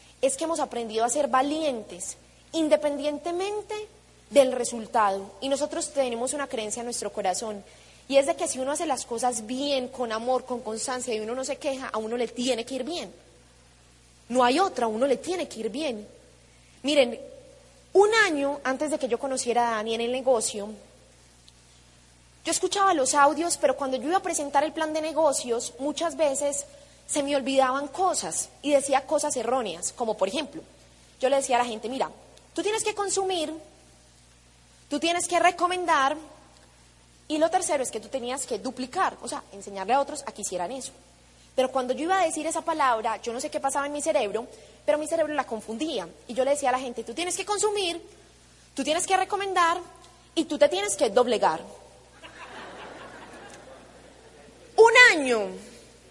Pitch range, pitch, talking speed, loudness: 230-315 Hz, 270 Hz, 185 wpm, -26 LUFS